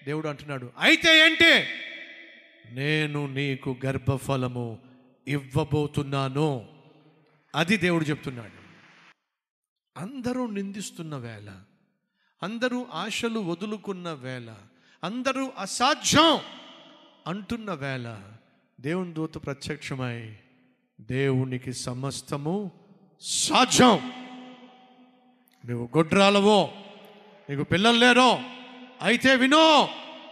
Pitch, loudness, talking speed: 165 Hz, -23 LUFS, 70 wpm